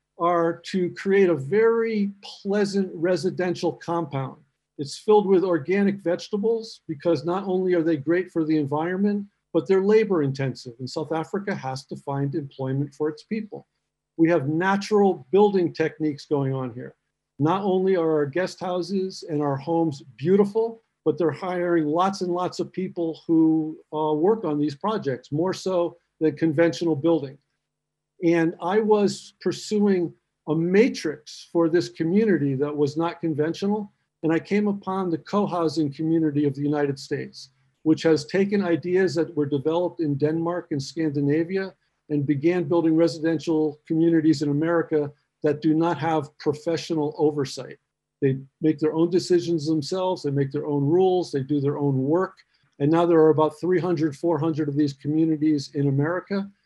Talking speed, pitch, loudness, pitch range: 160 wpm, 165 Hz, -24 LUFS, 150-180 Hz